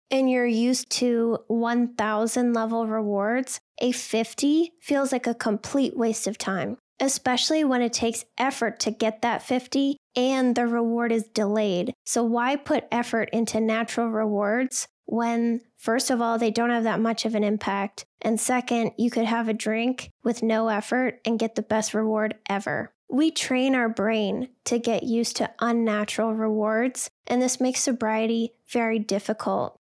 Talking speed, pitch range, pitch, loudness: 165 wpm, 220-250 Hz, 230 Hz, -25 LUFS